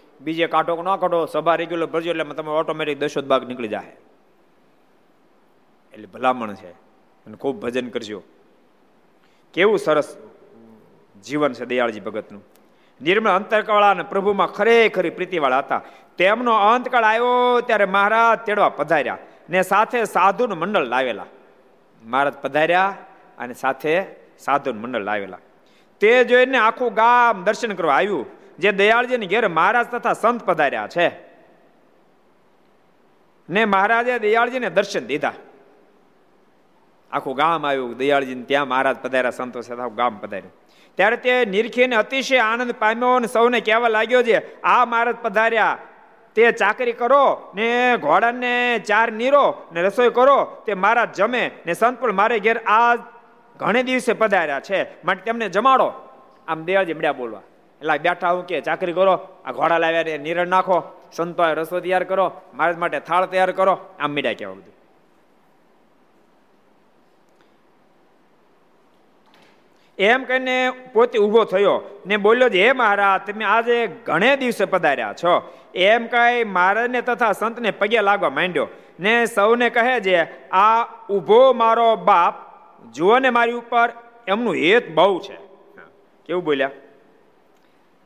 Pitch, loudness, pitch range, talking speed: 205 Hz, -19 LUFS, 165-235 Hz, 120 wpm